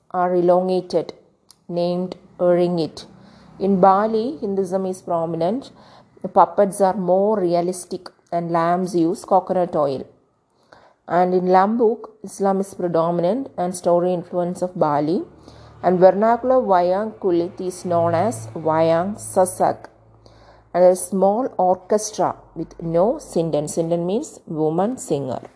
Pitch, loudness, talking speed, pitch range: 180 Hz, -20 LUFS, 115 wpm, 170-195 Hz